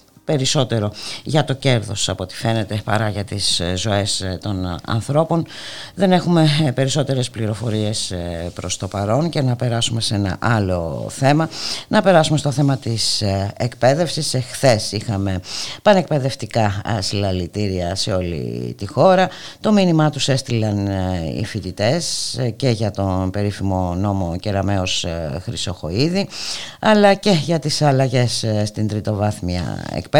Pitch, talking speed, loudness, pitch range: 110 Hz, 125 wpm, -19 LUFS, 100-135 Hz